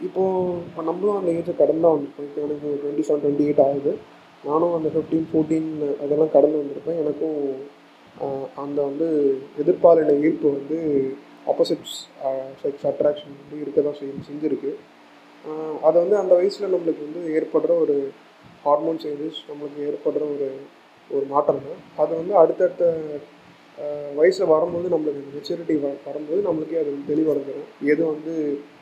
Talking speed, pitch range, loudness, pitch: 135 wpm, 145-165 Hz, -22 LUFS, 150 Hz